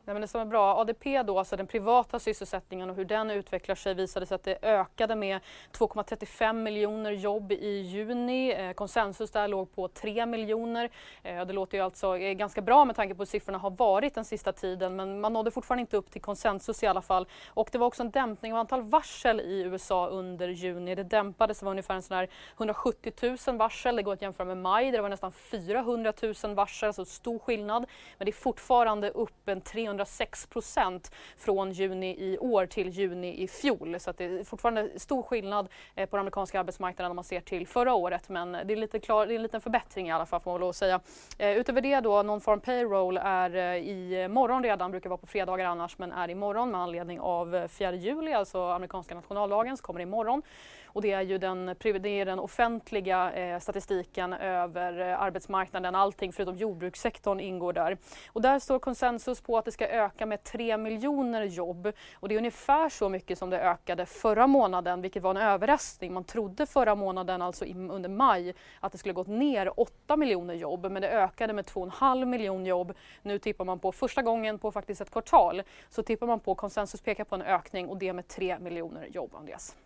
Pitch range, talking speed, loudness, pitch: 185-225 Hz, 210 wpm, -30 LUFS, 200 Hz